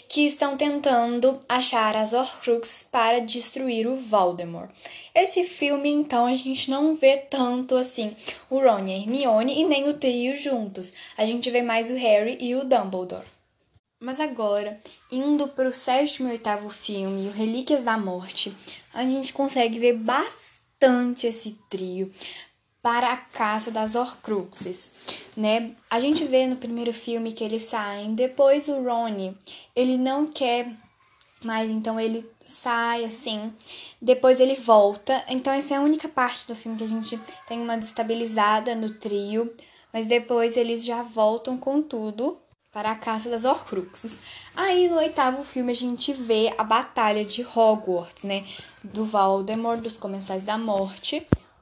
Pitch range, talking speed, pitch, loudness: 220-260 Hz, 155 wpm, 235 Hz, -24 LUFS